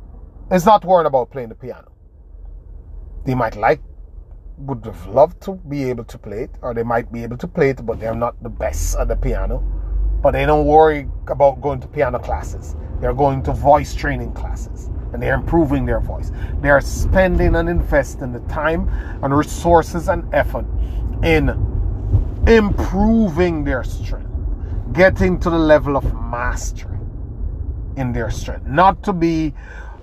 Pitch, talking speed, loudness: 110 Hz, 160 wpm, -18 LUFS